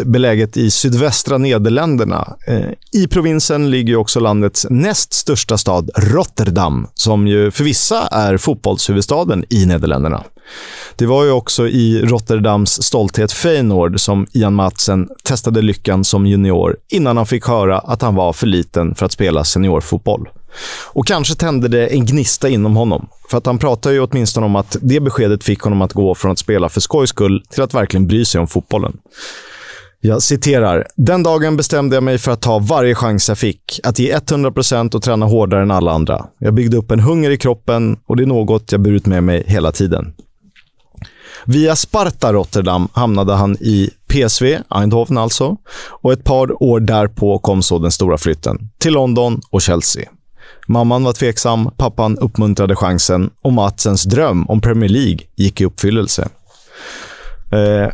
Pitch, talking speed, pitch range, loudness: 110 Hz, 170 wpm, 100-125 Hz, -14 LUFS